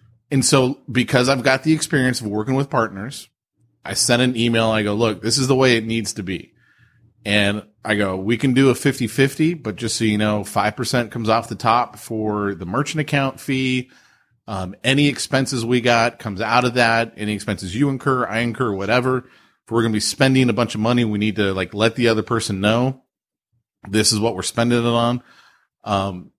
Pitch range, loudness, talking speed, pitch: 105-130 Hz, -19 LUFS, 210 wpm, 115 Hz